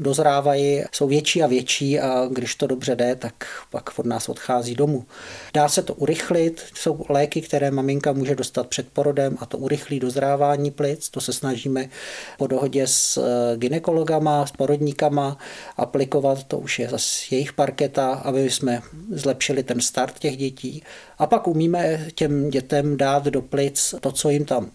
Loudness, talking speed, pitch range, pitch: -22 LUFS, 165 wpm, 130-150 Hz, 140 Hz